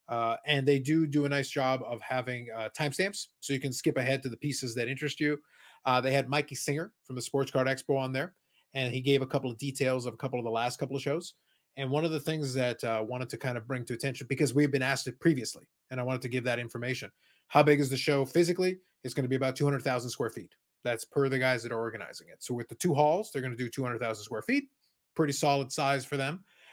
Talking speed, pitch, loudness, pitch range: 265 wpm, 135 Hz, -31 LUFS, 125-145 Hz